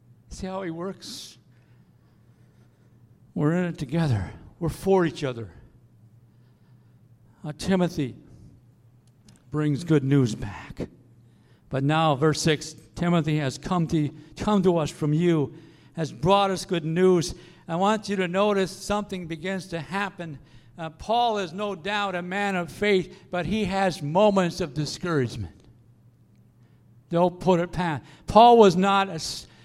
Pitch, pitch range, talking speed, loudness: 155 Hz, 120-185 Hz, 140 wpm, -24 LUFS